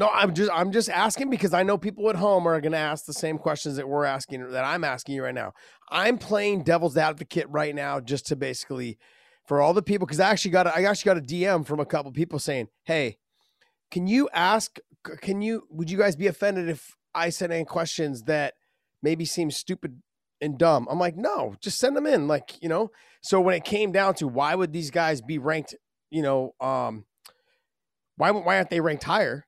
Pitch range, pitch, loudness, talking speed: 150-200 Hz, 170 Hz, -25 LUFS, 220 wpm